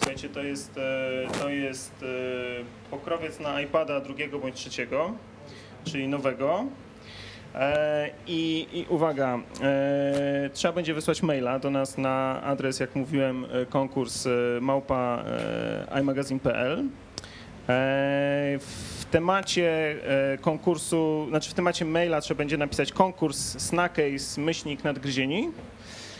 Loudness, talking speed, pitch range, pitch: -28 LUFS, 95 wpm, 130-155 Hz, 140 Hz